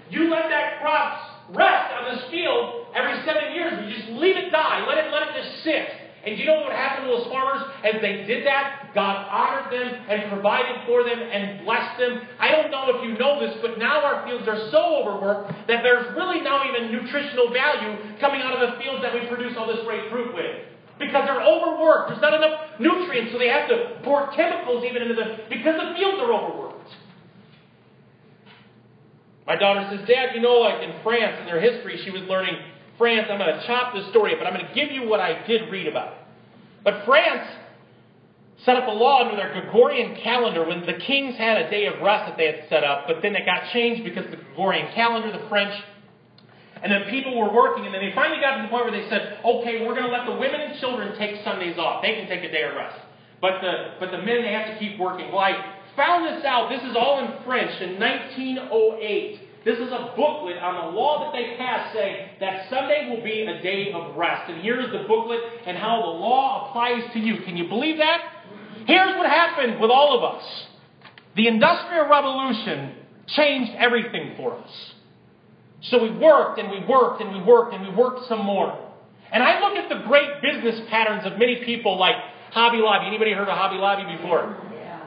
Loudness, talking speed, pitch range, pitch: -22 LUFS, 215 wpm, 205-275 Hz, 235 Hz